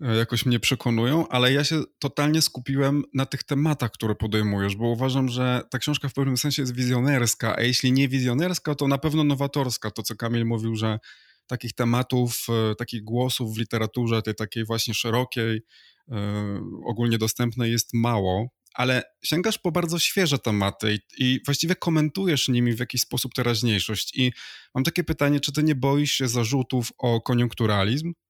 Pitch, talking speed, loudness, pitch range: 125 Hz, 160 wpm, -24 LUFS, 115-140 Hz